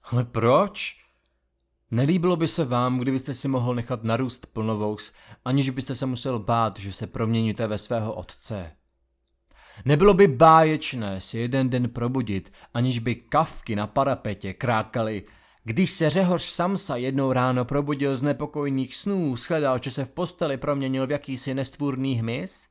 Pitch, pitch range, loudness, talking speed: 125 Hz, 110-145 Hz, -24 LUFS, 150 wpm